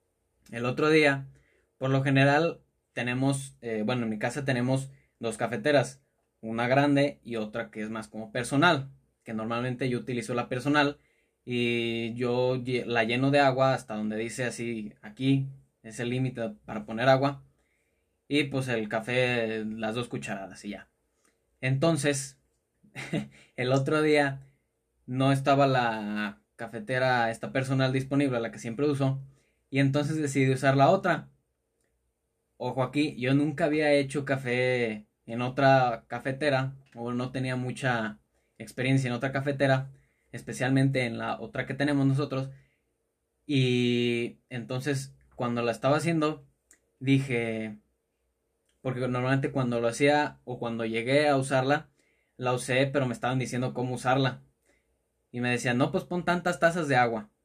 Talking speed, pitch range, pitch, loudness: 145 wpm, 115-135 Hz, 130 Hz, -28 LUFS